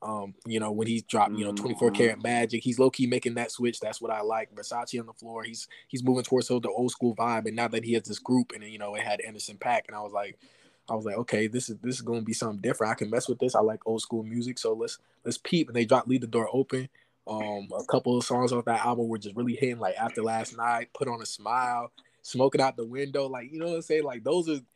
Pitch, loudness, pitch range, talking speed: 120 Hz, -29 LUFS, 110-125 Hz, 285 wpm